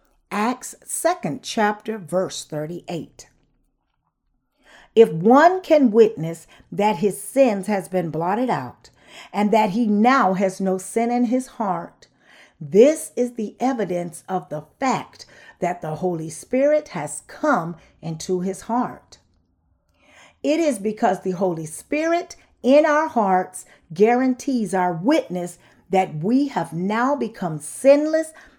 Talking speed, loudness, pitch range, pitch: 130 wpm, -21 LUFS, 180-255 Hz, 210 Hz